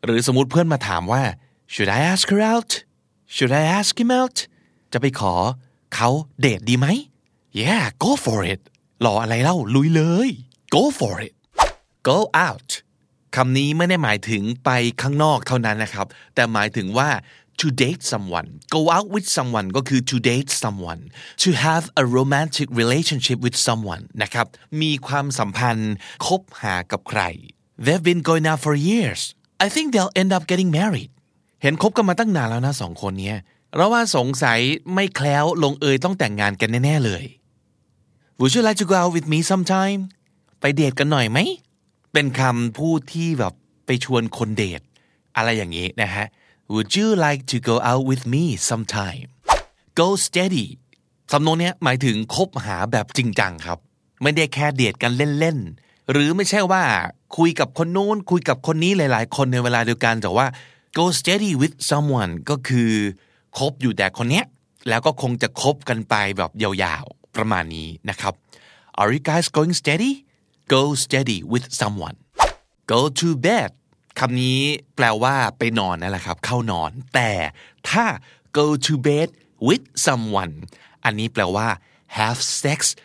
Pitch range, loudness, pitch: 110-160 Hz, -20 LUFS, 130 Hz